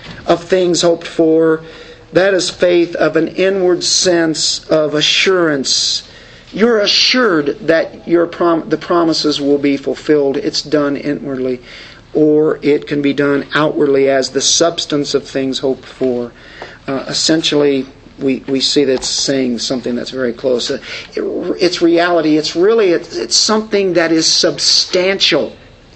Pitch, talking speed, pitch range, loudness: 155 Hz, 155 wpm, 140-170 Hz, -13 LUFS